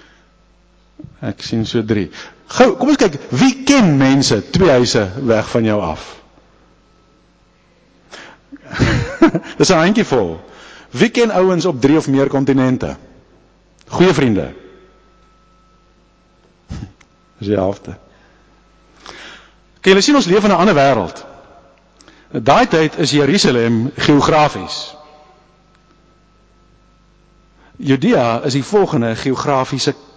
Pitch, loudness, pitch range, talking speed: 140 Hz, -14 LUFS, 115-160 Hz, 105 wpm